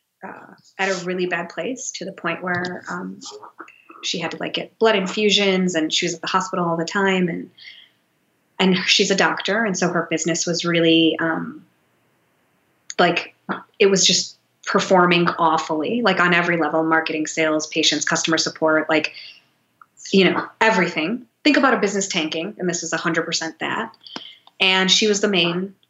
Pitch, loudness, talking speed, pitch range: 175 Hz, -19 LUFS, 175 wpm, 165-195 Hz